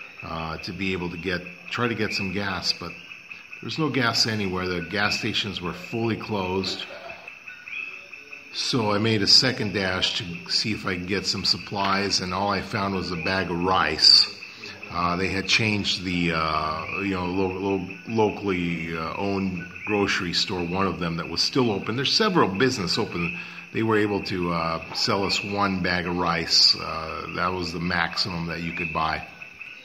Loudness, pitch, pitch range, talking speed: -23 LUFS, 95 Hz, 90-105 Hz, 185 wpm